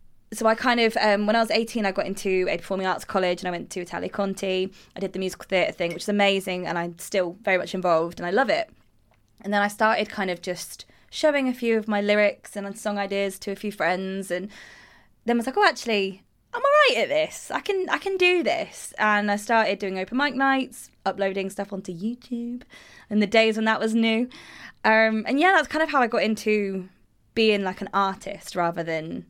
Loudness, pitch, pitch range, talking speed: -24 LUFS, 205 Hz, 190-230 Hz, 230 wpm